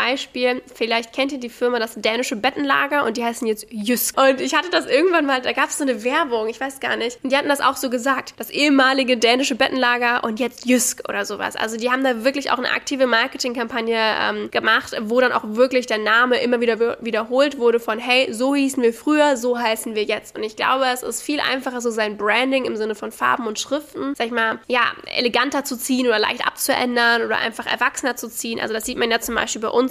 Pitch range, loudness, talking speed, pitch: 230-265 Hz, -20 LUFS, 235 wpm, 245 Hz